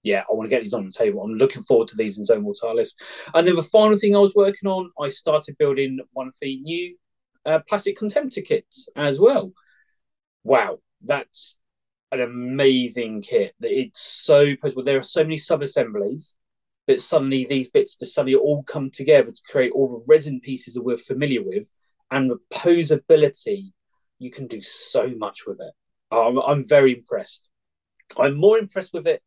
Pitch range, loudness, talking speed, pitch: 135-205 Hz, -21 LUFS, 185 wpm, 155 Hz